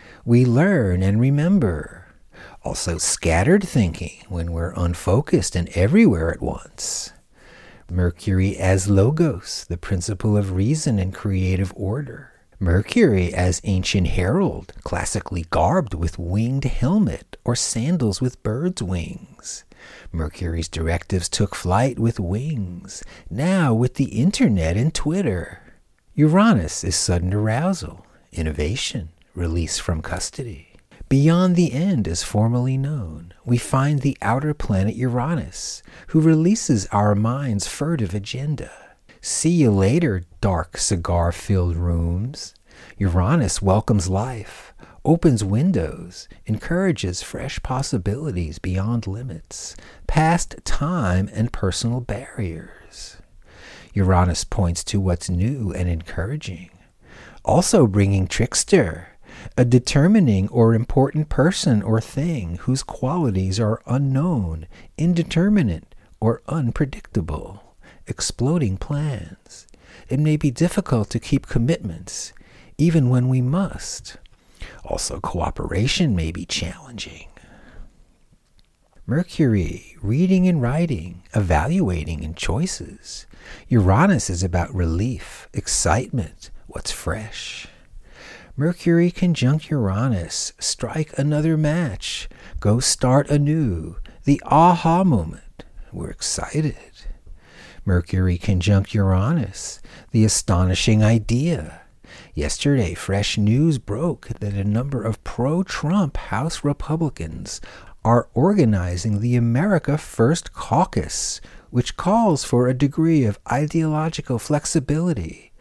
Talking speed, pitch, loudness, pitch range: 105 wpm, 115 Hz, -21 LUFS, 95-145 Hz